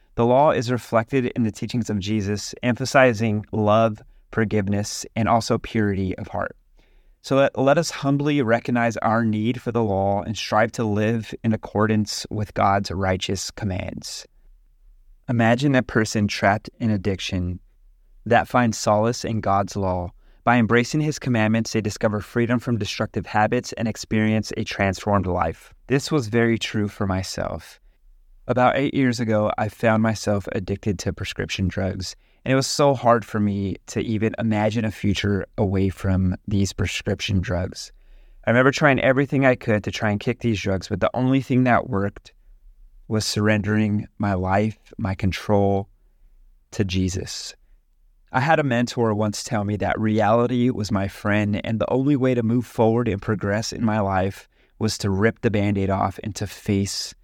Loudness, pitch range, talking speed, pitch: -22 LUFS, 100-120 Hz, 165 wpm, 110 Hz